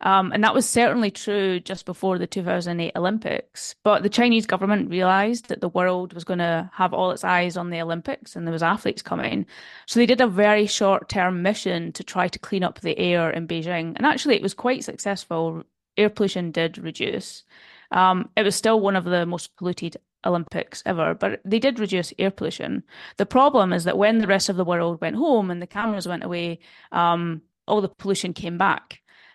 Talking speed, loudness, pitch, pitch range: 205 wpm, -23 LUFS, 190 Hz, 175-210 Hz